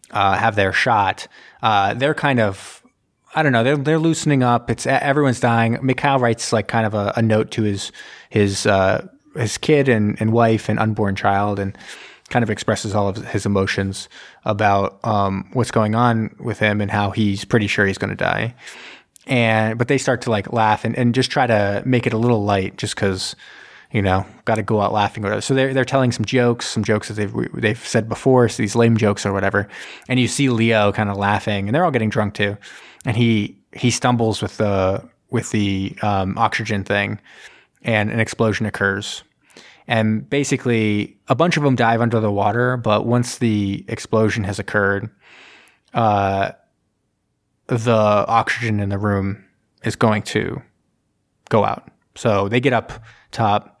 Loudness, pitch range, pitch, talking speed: -19 LUFS, 100-120 Hz, 110 Hz, 190 wpm